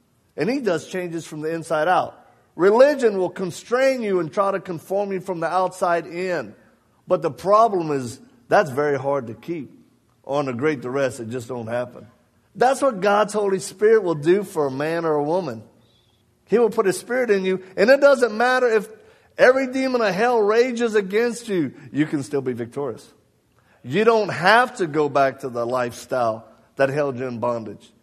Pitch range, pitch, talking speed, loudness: 135-215 Hz, 175 Hz, 190 wpm, -21 LUFS